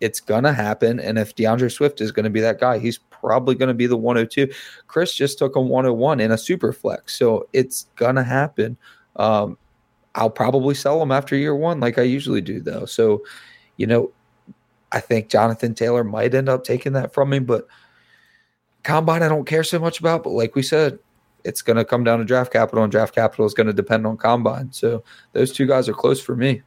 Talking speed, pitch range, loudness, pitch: 225 wpm, 115-140 Hz, -20 LUFS, 125 Hz